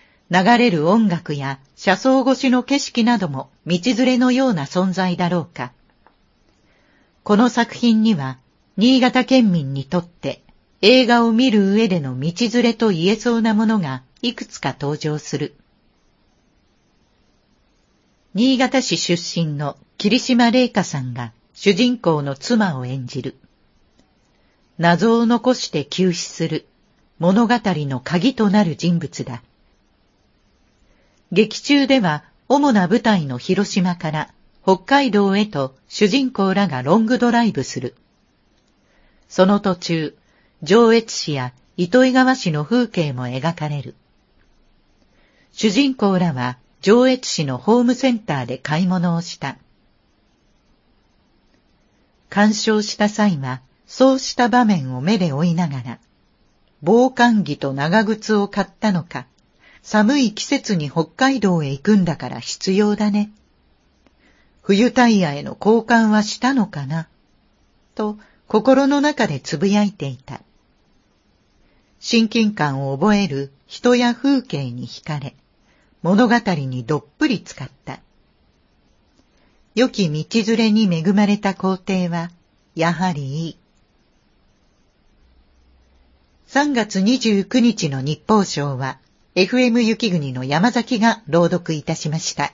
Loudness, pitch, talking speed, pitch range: -18 LUFS, 195 Hz, 215 characters per minute, 150-230 Hz